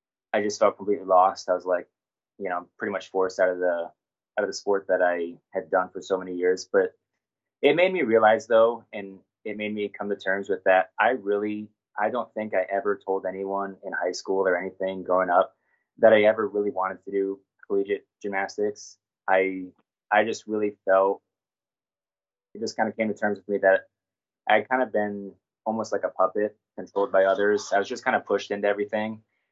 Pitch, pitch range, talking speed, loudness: 100 Hz, 95-105 Hz, 210 wpm, -25 LUFS